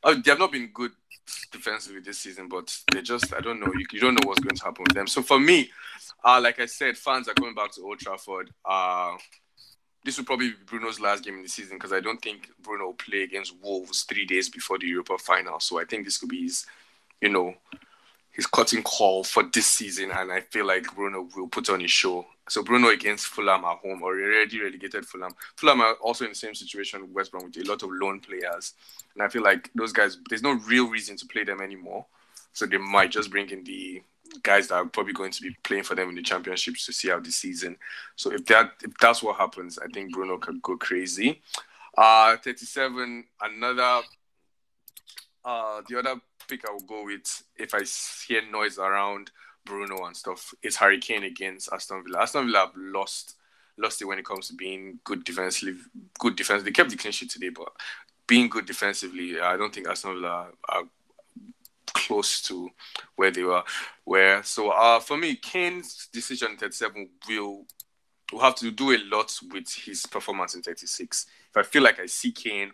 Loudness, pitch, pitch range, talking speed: -25 LUFS, 100 Hz, 95-130 Hz, 210 wpm